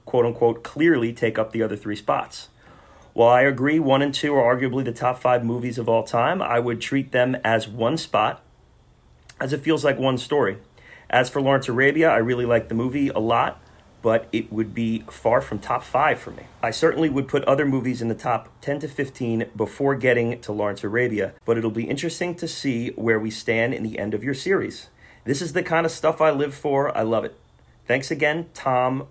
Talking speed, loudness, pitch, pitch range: 215 wpm, -22 LUFS, 125 Hz, 115-140 Hz